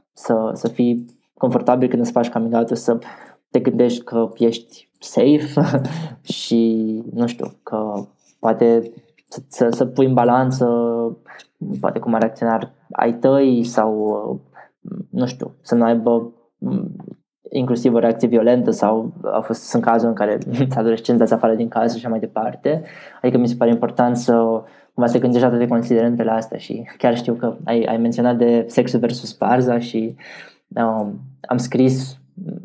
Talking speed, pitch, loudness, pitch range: 160 wpm, 120 Hz, -18 LUFS, 115-125 Hz